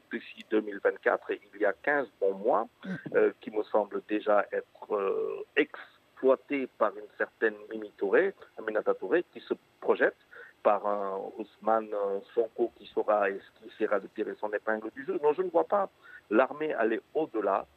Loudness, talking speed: -30 LUFS, 165 wpm